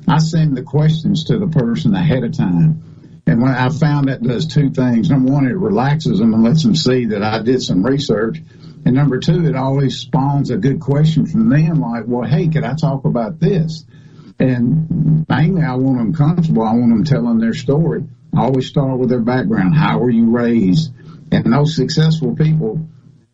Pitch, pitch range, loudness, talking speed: 150 Hz, 130-160 Hz, -15 LUFS, 200 wpm